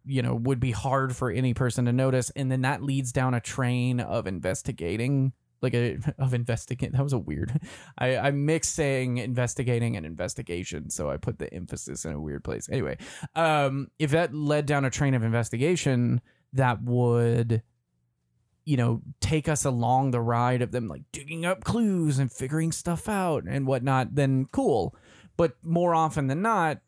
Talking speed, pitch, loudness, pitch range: 180 wpm, 130 Hz, -27 LUFS, 120-145 Hz